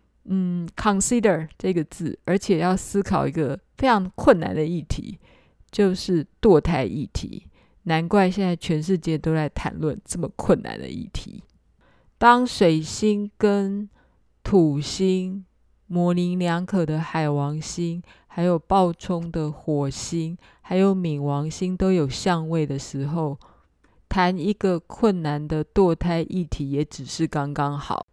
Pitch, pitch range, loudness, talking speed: 175 Hz, 155-190 Hz, -23 LUFS, 210 characters per minute